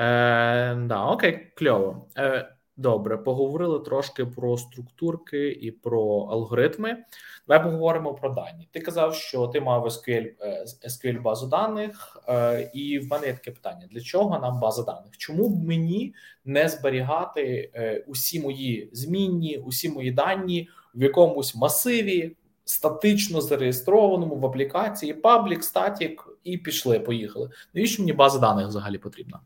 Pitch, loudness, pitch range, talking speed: 140 Hz, -24 LUFS, 120-170 Hz, 140 wpm